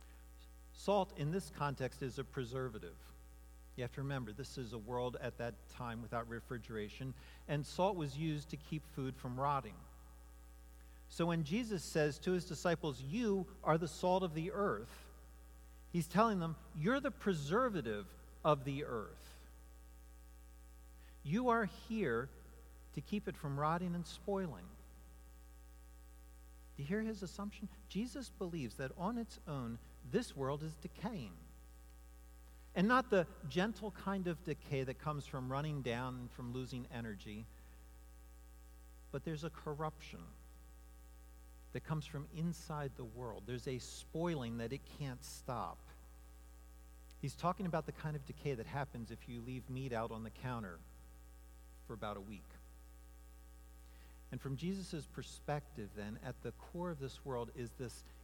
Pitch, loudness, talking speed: 125 Hz, -41 LUFS, 150 wpm